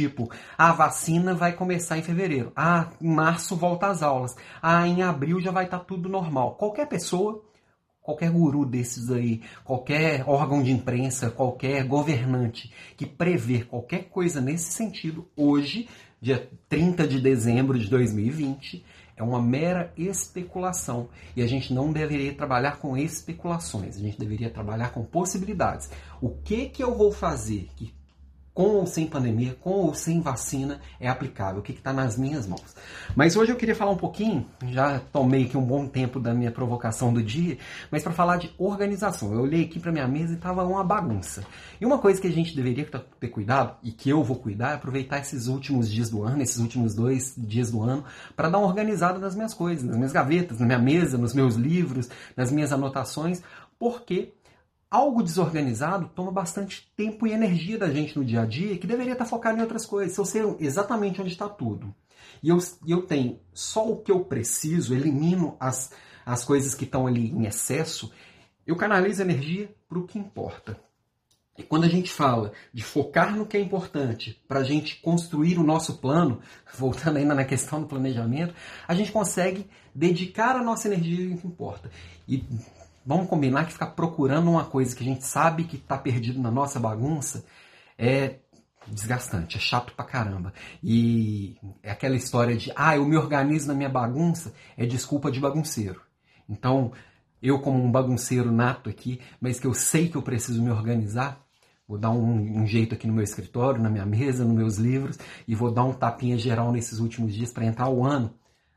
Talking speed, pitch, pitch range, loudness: 185 wpm, 140 Hz, 120-170 Hz, -26 LUFS